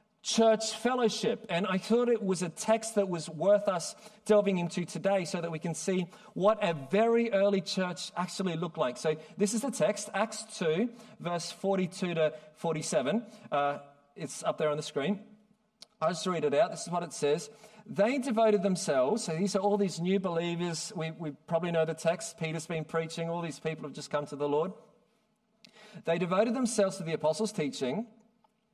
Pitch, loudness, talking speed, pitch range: 195 Hz, -31 LUFS, 190 wpm, 165-215 Hz